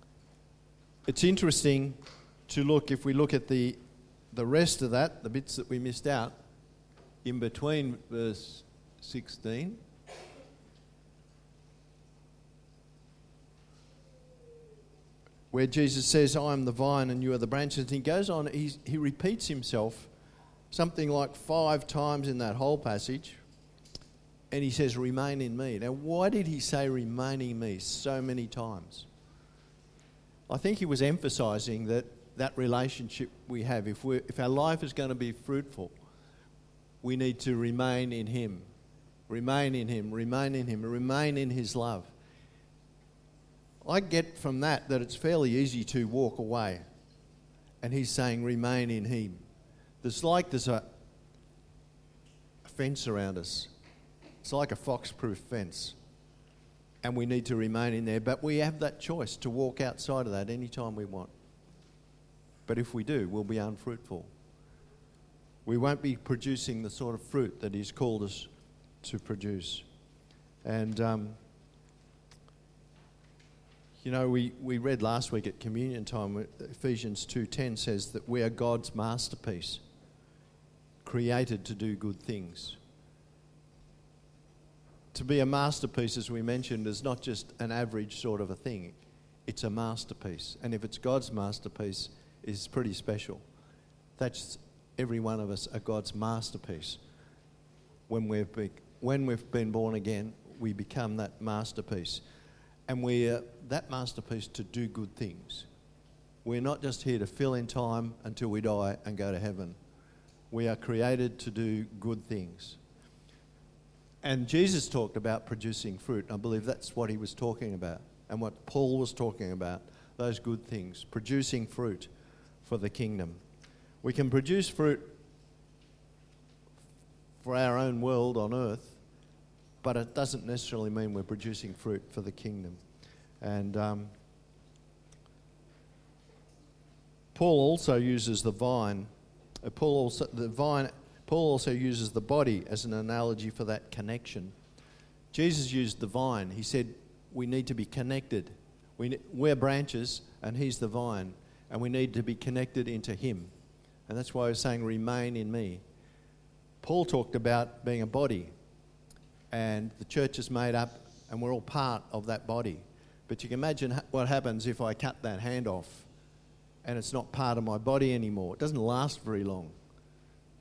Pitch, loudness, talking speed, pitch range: 120 Hz, -33 LUFS, 150 wpm, 110-135 Hz